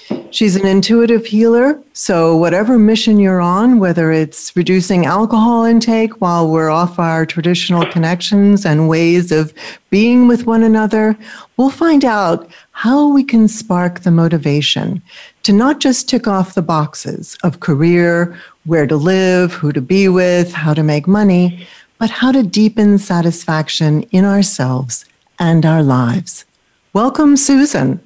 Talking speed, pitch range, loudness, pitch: 145 wpm, 165-220 Hz, -12 LUFS, 185 Hz